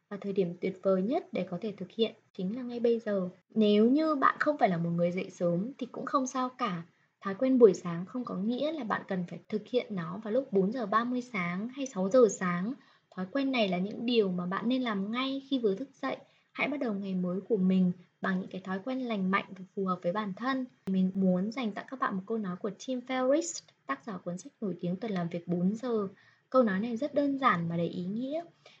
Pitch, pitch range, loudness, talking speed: 210 Hz, 185-250 Hz, -31 LUFS, 255 wpm